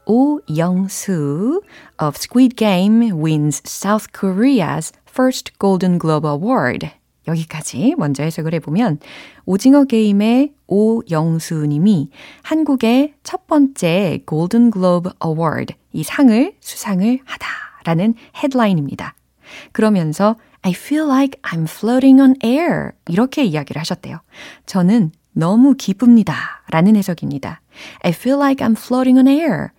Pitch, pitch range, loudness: 210 Hz, 165-260 Hz, -16 LUFS